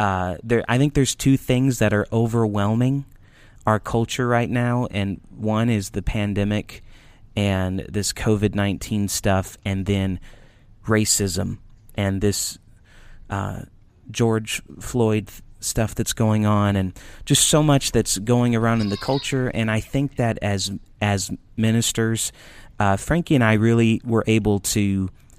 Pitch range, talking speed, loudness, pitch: 100-115 Hz, 145 wpm, -21 LUFS, 110 Hz